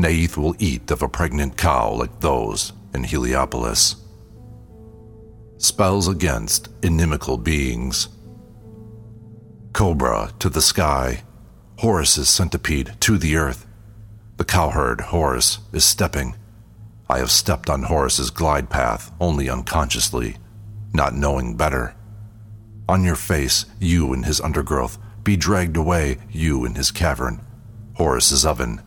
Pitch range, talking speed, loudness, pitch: 75-105 Hz, 120 wpm, -19 LUFS, 90 Hz